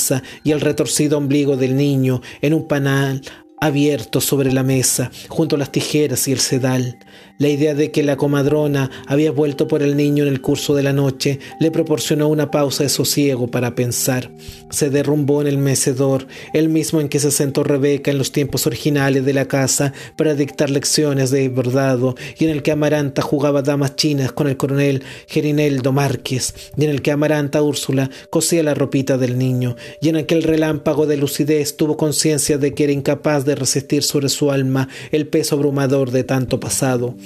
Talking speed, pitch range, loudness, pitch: 185 wpm, 135-150 Hz, -17 LUFS, 145 Hz